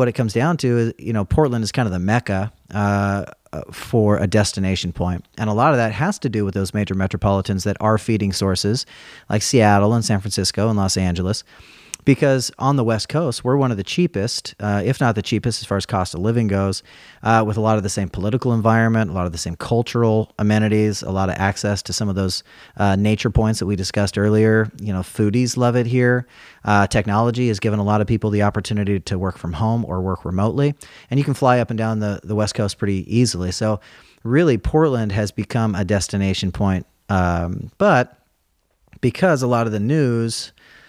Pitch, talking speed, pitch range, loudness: 105 Hz, 220 wpm, 100-115 Hz, -19 LUFS